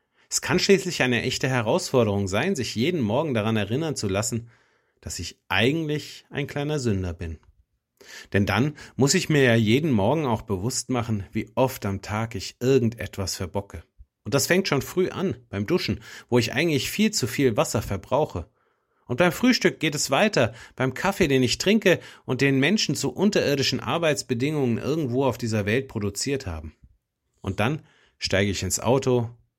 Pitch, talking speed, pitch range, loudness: 125 Hz, 170 wpm, 105-145 Hz, -24 LUFS